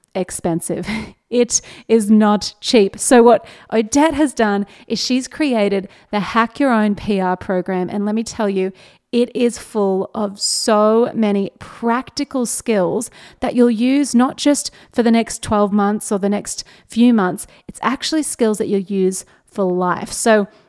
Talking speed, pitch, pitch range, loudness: 160 wpm, 215 Hz, 200-240 Hz, -17 LUFS